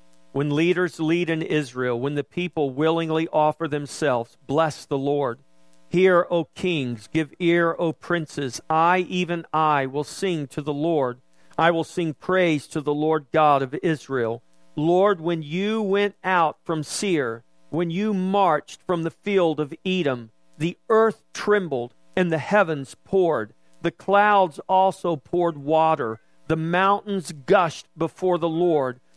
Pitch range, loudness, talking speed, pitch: 145-180 Hz, -23 LUFS, 150 wpm, 160 Hz